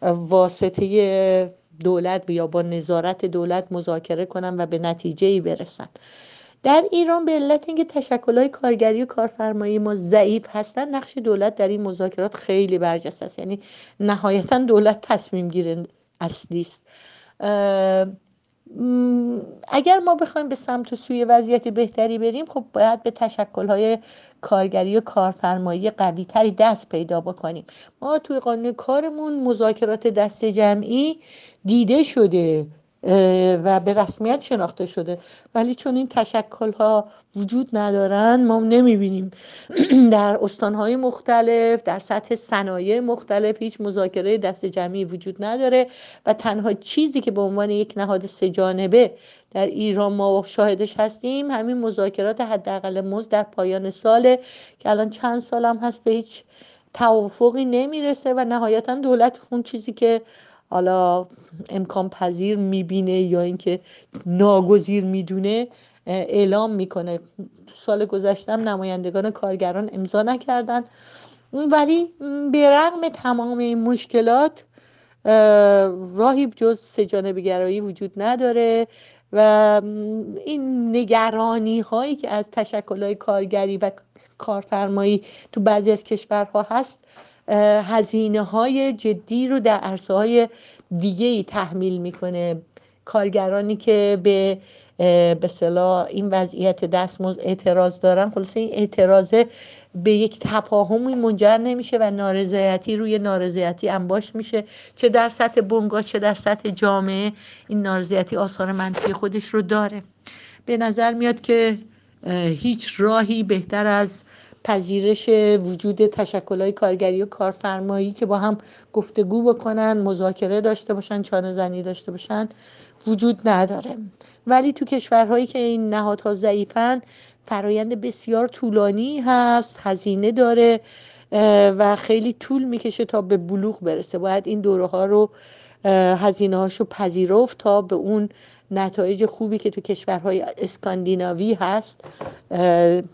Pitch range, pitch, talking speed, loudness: 195-235 Hz, 210 Hz, 125 wpm, -20 LUFS